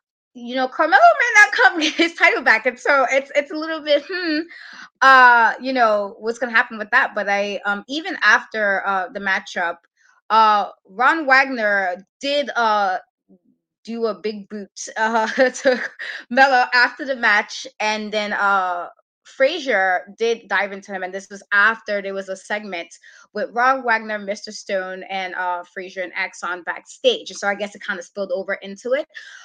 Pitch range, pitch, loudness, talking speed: 195-265 Hz, 215 Hz, -18 LUFS, 175 wpm